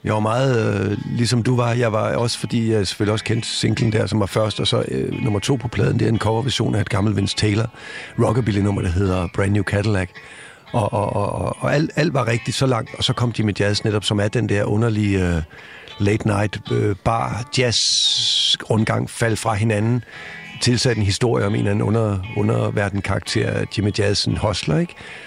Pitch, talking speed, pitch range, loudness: 110 Hz, 190 wpm, 105-120 Hz, -20 LUFS